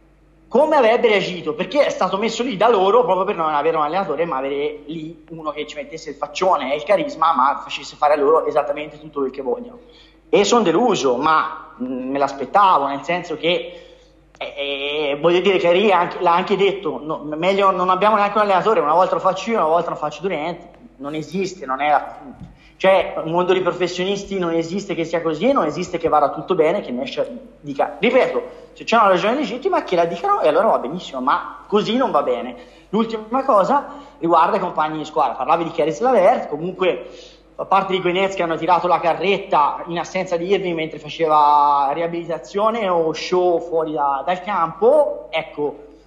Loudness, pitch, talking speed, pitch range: -18 LUFS, 170 Hz, 195 wpm, 155-195 Hz